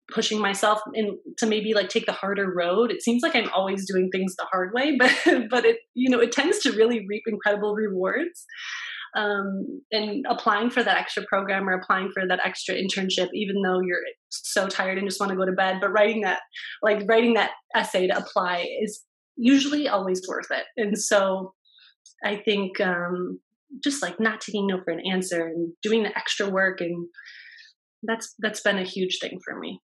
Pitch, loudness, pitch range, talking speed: 210 Hz, -24 LUFS, 190-230 Hz, 195 wpm